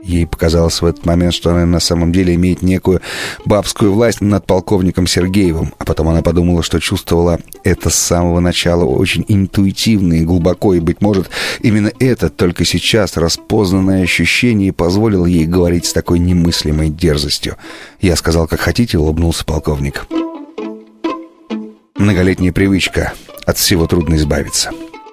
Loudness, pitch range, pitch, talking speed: -13 LUFS, 85-100 Hz, 90 Hz, 140 wpm